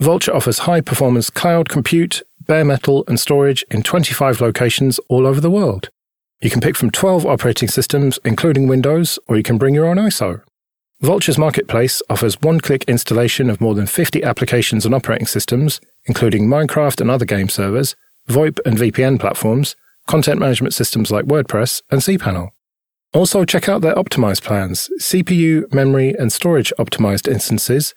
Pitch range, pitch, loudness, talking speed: 115-155 Hz, 135 Hz, -15 LUFS, 165 wpm